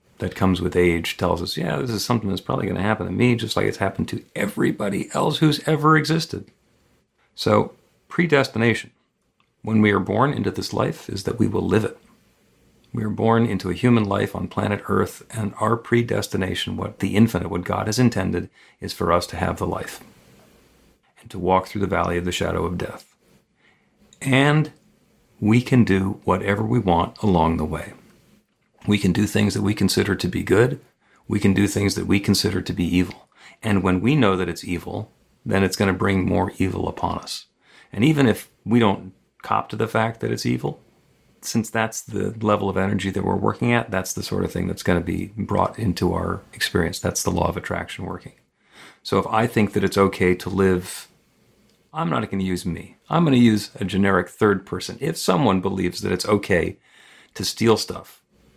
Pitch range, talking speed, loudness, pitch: 90-115 Hz, 205 wpm, -22 LUFS, 100 Hz